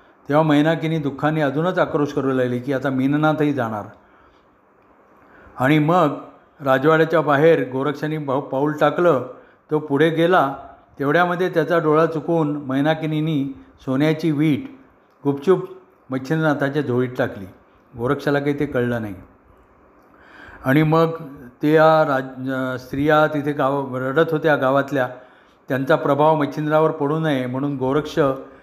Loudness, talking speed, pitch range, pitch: -19 LUFS, 115 wpm, 135-155 Hz, 150 Hz